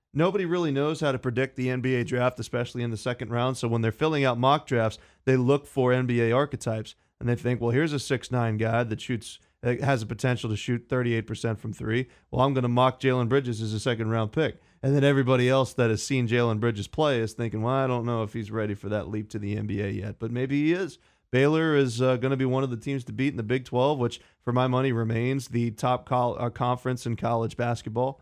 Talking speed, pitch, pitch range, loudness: 245 wpm, 125 Hz, 115-130 Hz, -26 LUFS